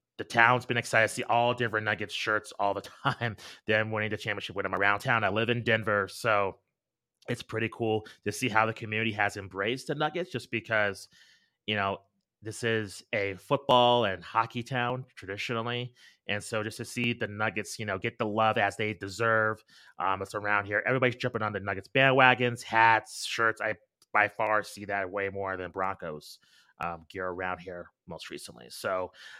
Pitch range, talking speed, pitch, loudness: 100-120 Hz, 190 wpm, 110 Hz, -29 LUFS